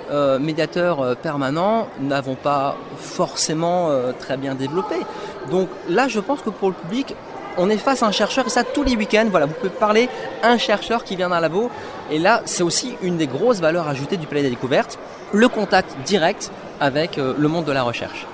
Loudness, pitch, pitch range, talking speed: -20 LUFS, 180 Hz, 145-220 Hz, 205 wpm